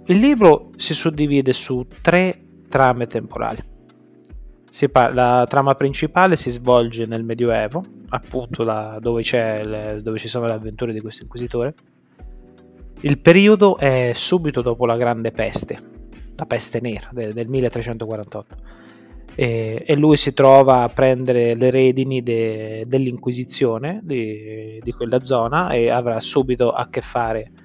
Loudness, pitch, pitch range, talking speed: -17 LUFS, 120 Hz, 110-130 Hz, 140 wpm